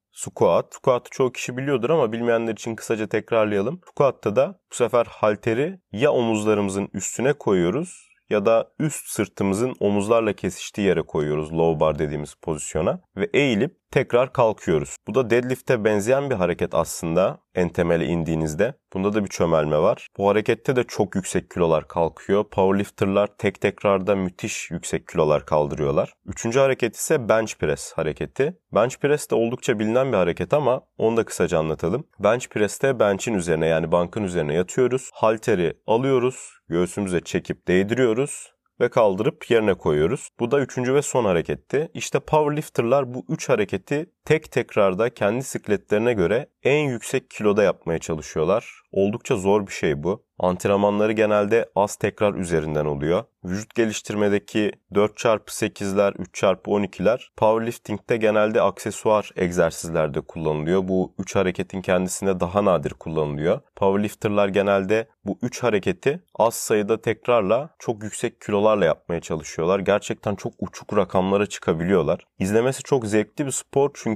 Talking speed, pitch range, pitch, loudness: 140 wpm, 95-120 Hz, 105 Hz, -22 LUFS